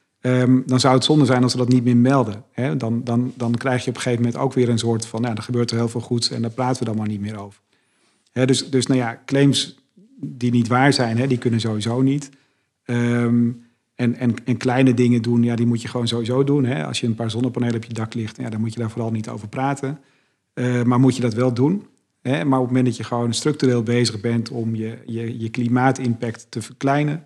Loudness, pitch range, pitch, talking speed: -20 LUFS, 115-130 Hz, 120 Hz, 255 wpm